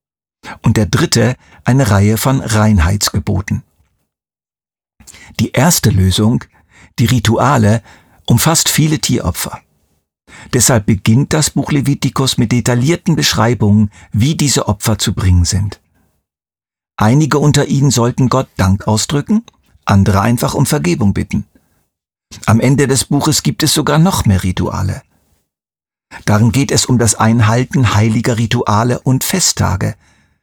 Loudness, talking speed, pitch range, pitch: -13 LUFS, 120 wpm, 100-135 Hz, 115 Hz